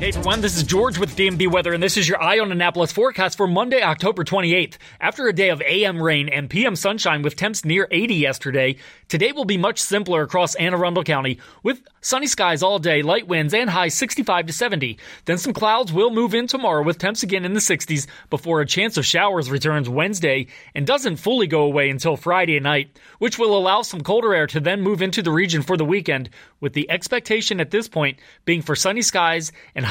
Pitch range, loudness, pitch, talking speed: 155-205 Hz, -19 LUFS, 180 Hz, 220 wpm